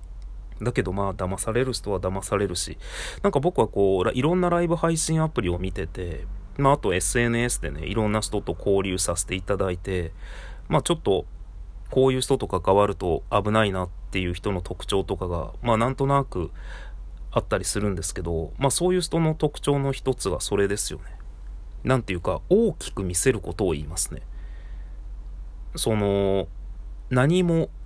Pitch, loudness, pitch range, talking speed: 100 Hz, -24 LUFS, 90-130 Hz, 335 characters per minute